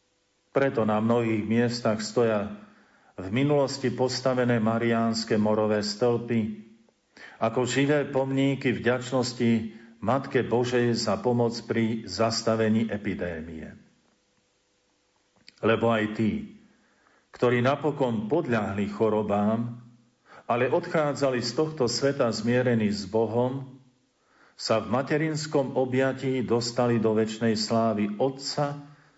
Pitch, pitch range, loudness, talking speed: 120 Hz, 110-130 Hz, -26 LUFS, 95 wpm